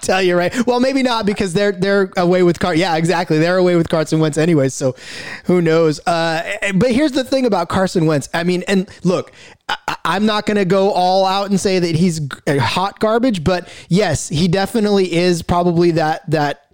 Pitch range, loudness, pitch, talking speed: 165-200 Hz, -16 LUFS, 180 Hz, 205 wpm